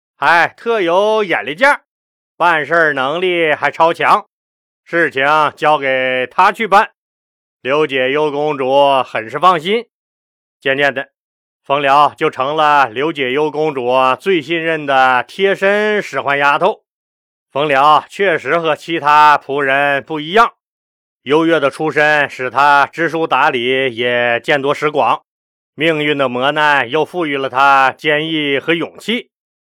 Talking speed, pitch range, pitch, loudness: 195 characters per minute, 135-165 Hz, 150 Hz, -13 LUFS